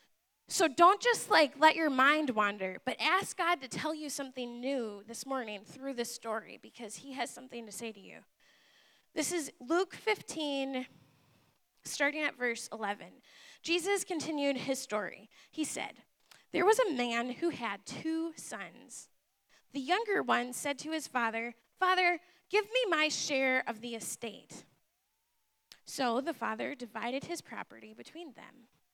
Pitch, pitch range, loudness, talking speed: 270 Hz, 235-325 Hz, -33 LUFS, 155 wpm